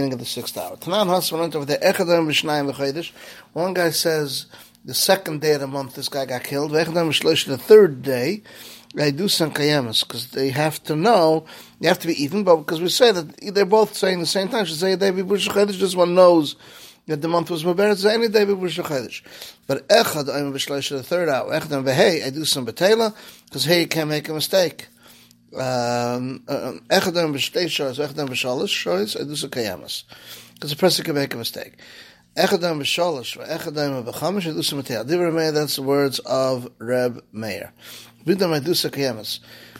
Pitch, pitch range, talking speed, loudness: 155 Hz, 140-180 Hz, 190 wpm, -20 LUFS